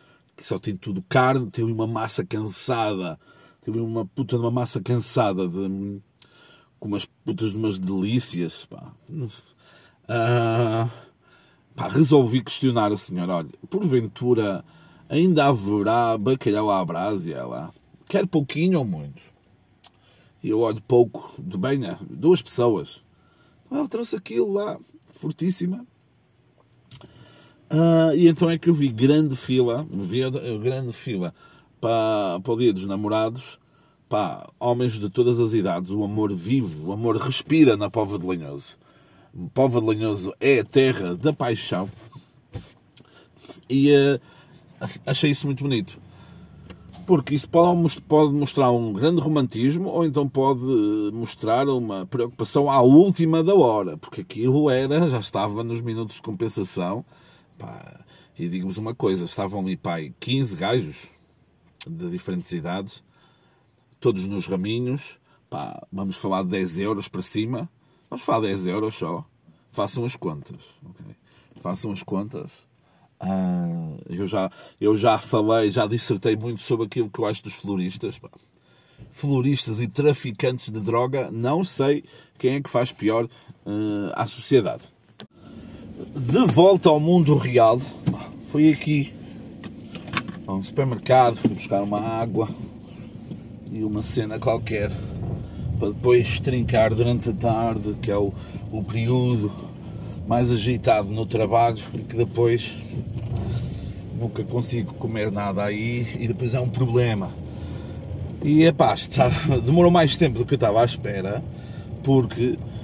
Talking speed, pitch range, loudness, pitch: 135 wpm, 105-140 Hz, -23 LUFS, 120 Hz